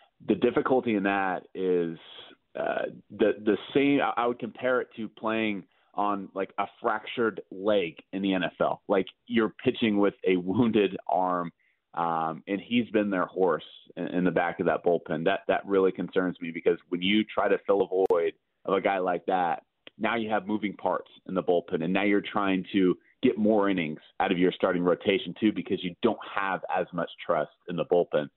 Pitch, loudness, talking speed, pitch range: 100 Hz, -28 LUFS, 195 wpm, 95-115 Hz